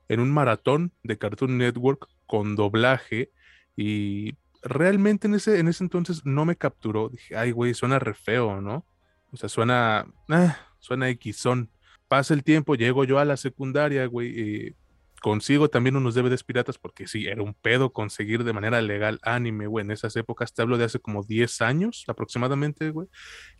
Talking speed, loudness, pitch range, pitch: 175 wpm, -25 LUFS, 110-140 Hz, 120 Hz